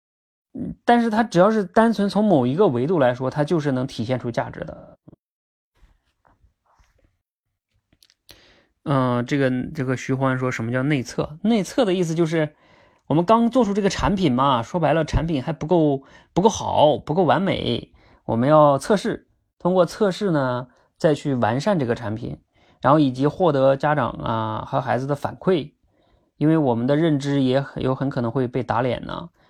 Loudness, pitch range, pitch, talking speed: -21 LUFS, 125-165 Hz, 140 Hz, 255 characters per minute